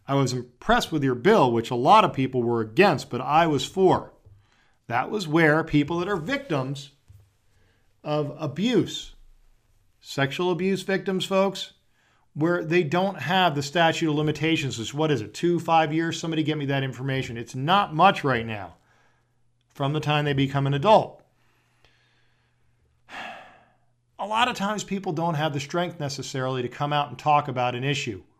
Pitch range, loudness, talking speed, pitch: 125-175 Hz, -24 LUFS, 170 wpm, 145 Hz